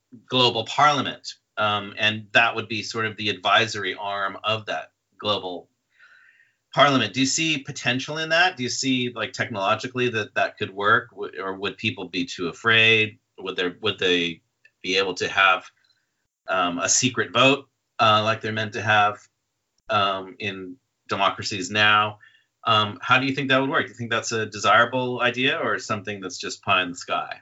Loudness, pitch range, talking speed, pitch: -22 LUFS, 105-125 Hz, 180 wpm, 110 Hz